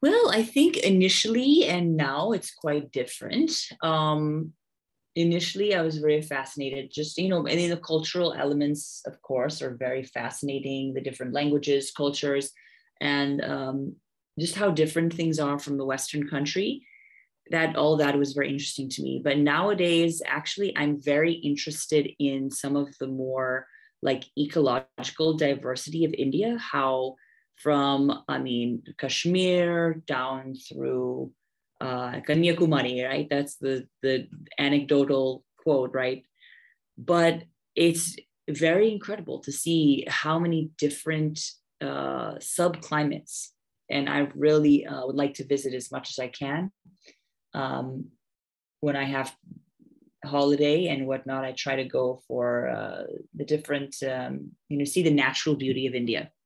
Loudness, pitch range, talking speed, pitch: -26 LUFS, 135-165 Hz, 140 wpm, 145 Hz